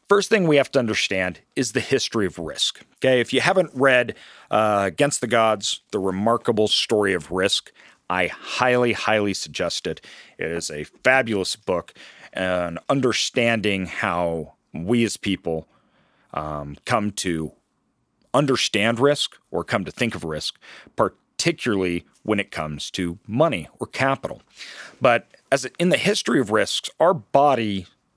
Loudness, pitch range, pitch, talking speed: -22 LUFS, 90-130 Hz, 110 Hz, 145 wpm